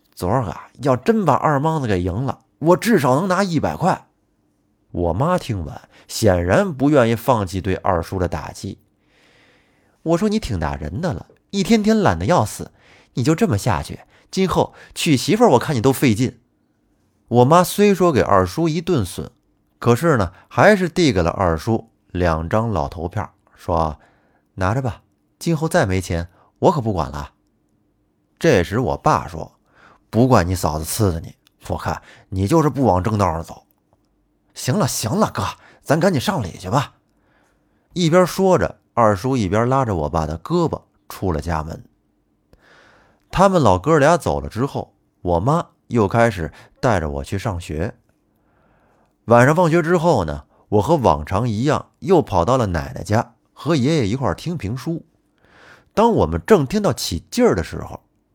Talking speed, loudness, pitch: 230 characters per minute, -19 LUFS, 115 Hz